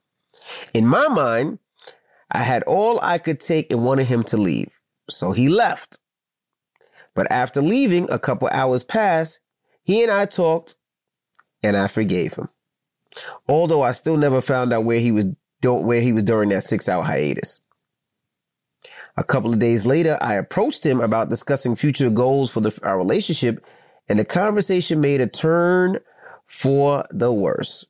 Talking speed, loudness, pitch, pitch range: 155 wpm, -17 LUFS, 130 Hz, 115-160 Hz